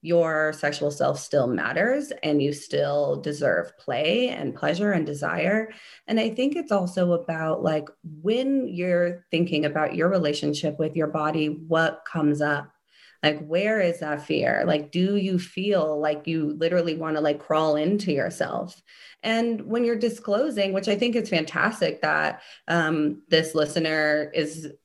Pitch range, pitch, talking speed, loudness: 150-195 Hz, 165 Hz, 155 wpm, -25 LUFS